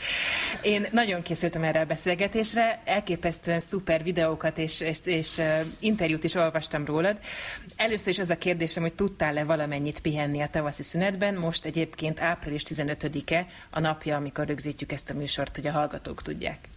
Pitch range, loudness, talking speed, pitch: 150-180 Hz, -27 LUFS, 155 wpm, 160 Hz